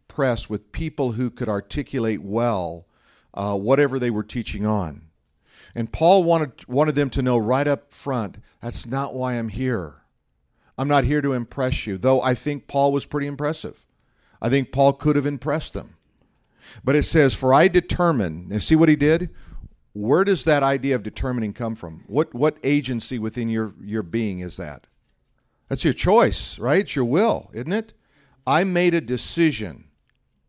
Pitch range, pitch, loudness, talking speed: 110-145 Hz, 130 Hz, -22 LUFS, 175 wpm